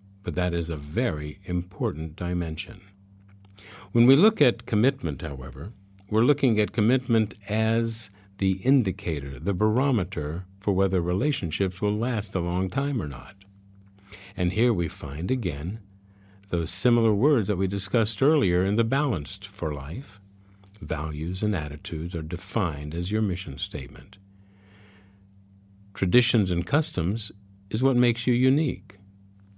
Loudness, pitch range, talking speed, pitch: -26 LUFS, 90-110 Hz, 135 wpm, 100 Hz